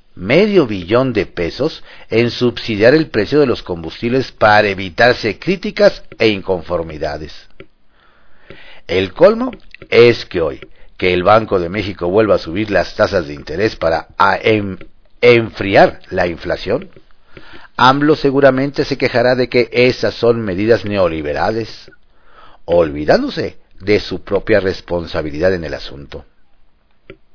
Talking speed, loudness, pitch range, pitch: 125 wpm, -14 LUFS, 95-125 Hz, 110 Hz